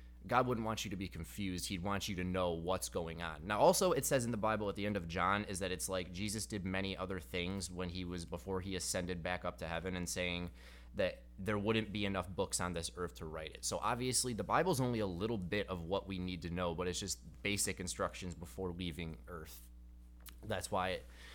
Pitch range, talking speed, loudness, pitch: 85-100 Hz, 240 wpm, -38 LUFS, 90 Hz